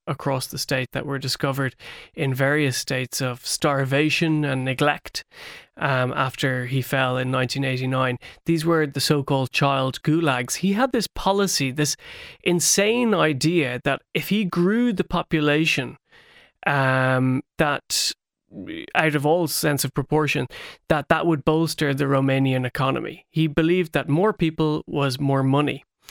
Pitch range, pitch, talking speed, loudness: 135-165 Hz, 145 Hz, 140 wpm, -22 LUFS